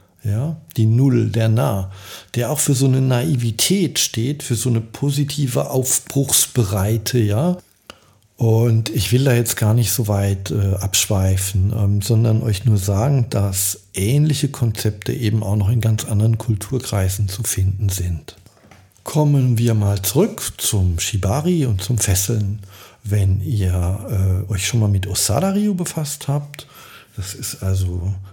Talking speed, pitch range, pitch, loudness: 145 wpm, 100-130 Hz, 110 Hz, -18 LUFS